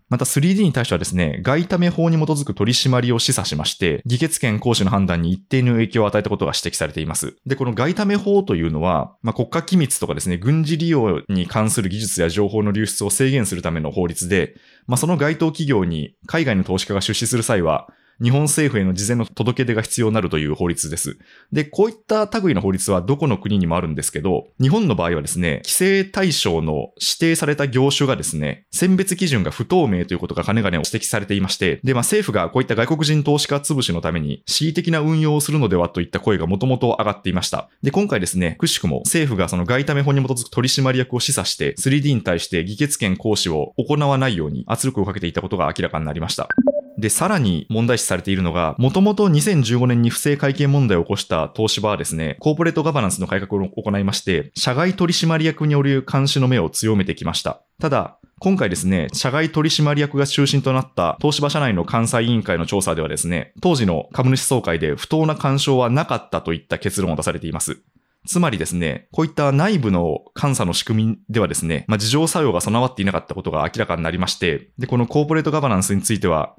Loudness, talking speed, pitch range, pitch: -19 LUFS, 440 characters per minute, 95-145 Hz, 120 Hz